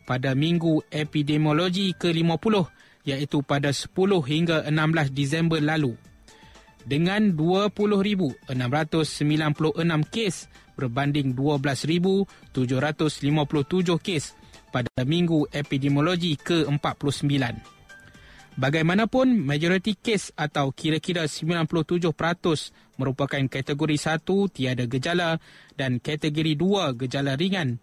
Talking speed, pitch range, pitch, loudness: 80 wpm, 140-170 Hz, 155 Hz, -24 LUFS